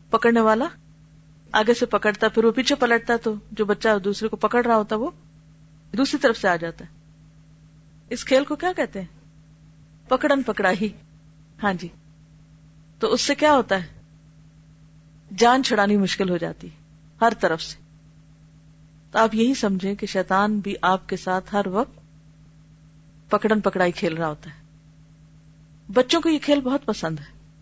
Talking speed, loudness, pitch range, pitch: 160 wpm, -22 LUFS, 155-220 Hz, 185 Hz